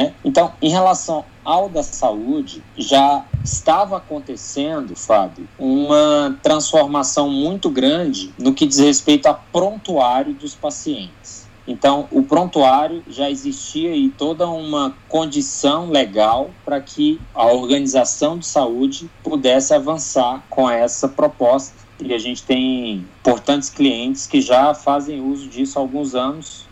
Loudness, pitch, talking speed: -17 LUFS, 150 Hz, 130 wpm